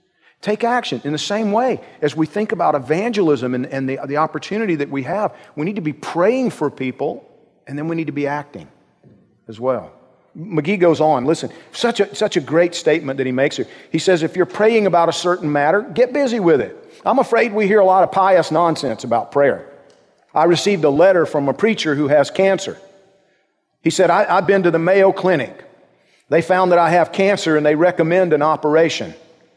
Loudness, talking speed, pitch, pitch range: -17 LUFS, 210 wpm, 170 Hz, 150-195 Hz